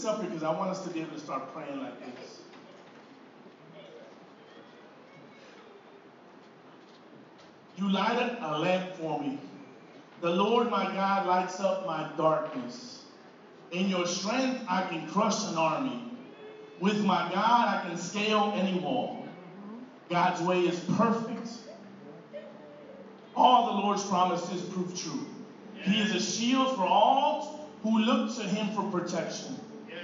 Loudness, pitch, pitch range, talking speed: -29 LUFS, 195 Hz, 180-230 Hz, 130 wpm